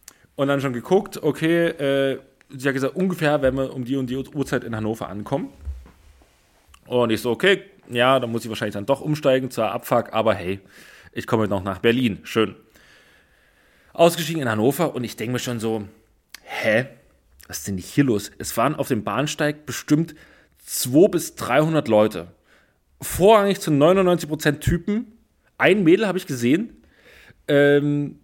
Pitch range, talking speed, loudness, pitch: 110-150 Hz, 165 wpm, -21 LUFS, 135 Hz